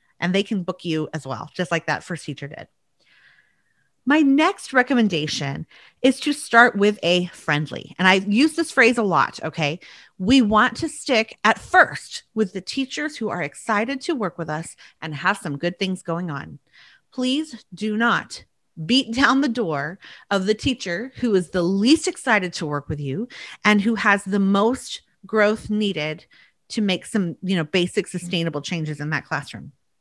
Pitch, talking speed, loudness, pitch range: 195 Hz, 180 wpm, -21 LUFS, 160-235 Hz